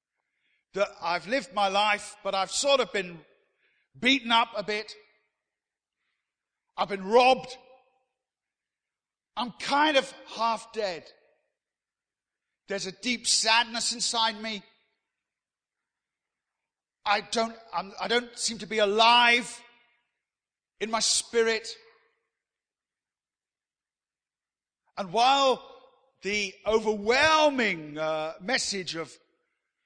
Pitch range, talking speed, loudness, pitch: 200-250 Hz, 95 wpm, -26 LUFS, 225 Hz